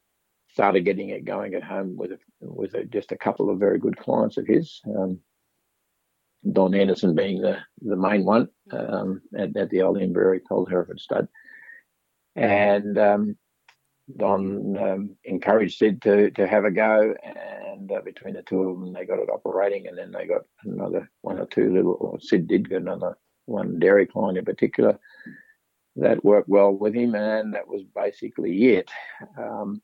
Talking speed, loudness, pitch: 175 wpm, -23 LUFS, 105 Hz